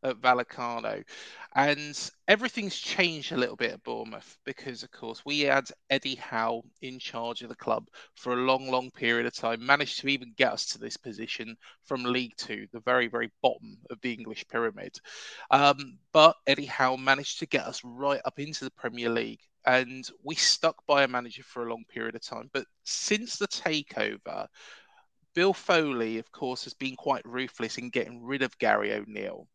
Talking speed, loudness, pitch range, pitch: 185 wpm, -28 LUFS, 120-140 Hz, 130 Hz